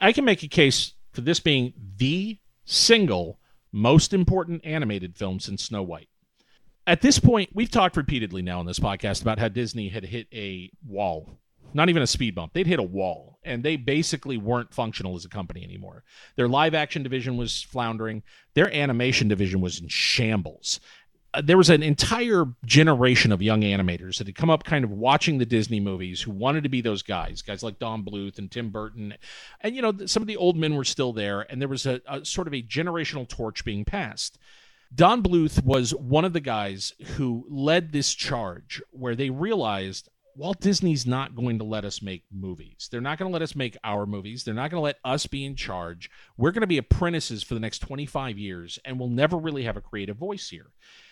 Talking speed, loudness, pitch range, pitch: 210 wpm, -24 LUFS, 105-155 Hz, 125 Hz